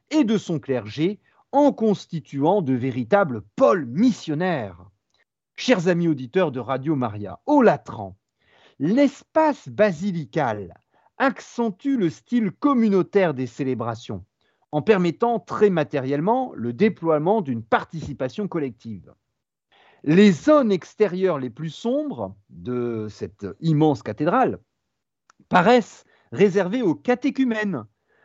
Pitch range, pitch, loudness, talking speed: 130-225 Hz, 175 Hz, -22 LUFS, 105 wpm